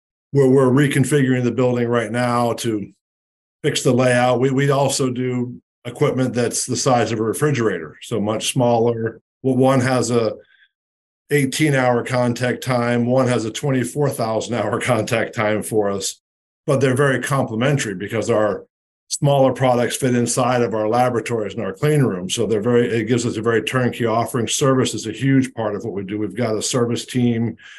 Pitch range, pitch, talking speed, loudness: 115-130 Hz, 120 Hz, 180 wpm, -19 LUFS